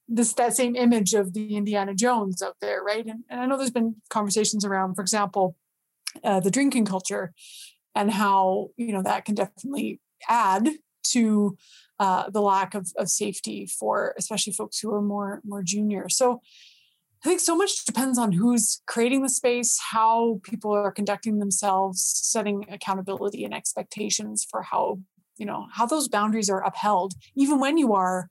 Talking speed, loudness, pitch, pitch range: 170 wpm, -24 LUFS, 210 Hz, 195-240 Hz